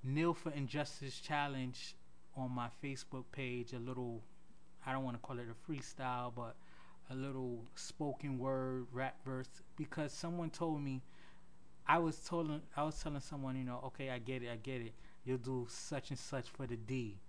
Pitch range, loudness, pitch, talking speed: 125-145 Hz, -43 LUFS, 130 Hz, 185 wpm